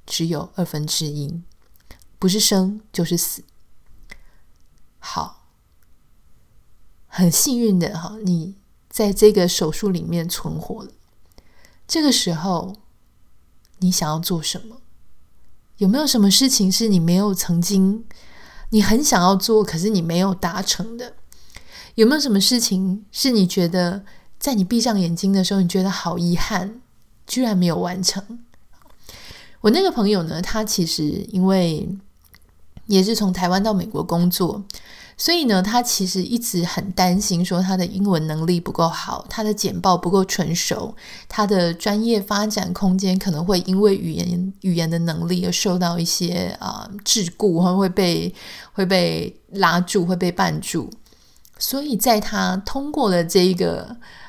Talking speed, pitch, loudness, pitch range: 215 characters per minute, 190 Hz, -19 LUFS, 175-205 Hz